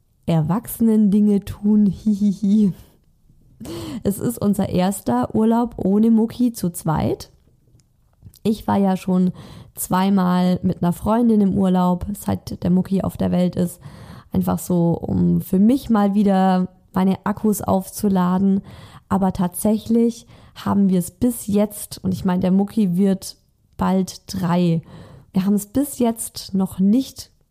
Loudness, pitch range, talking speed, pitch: -20 LUFS, 180-210 Hz, 140 wpm, 190 Hz